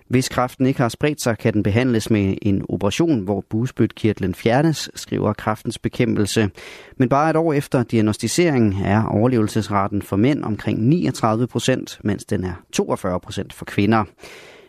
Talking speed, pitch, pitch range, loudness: 155 wpm, 115 Hz, 105-130 Hz, -20 LUFS